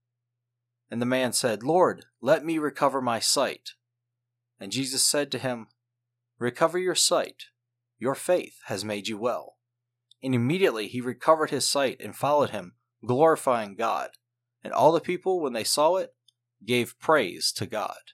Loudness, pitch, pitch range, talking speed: -25 LUFS, 120 Hz, 120-135 Hz, 155 wpm